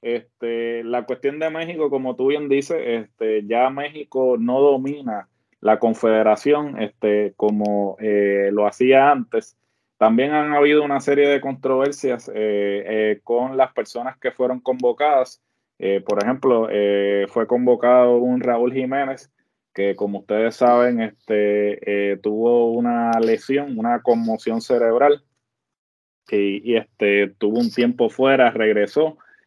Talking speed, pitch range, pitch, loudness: 135 wpm, 105-135 Hz, 120 Hz, -19 LUFS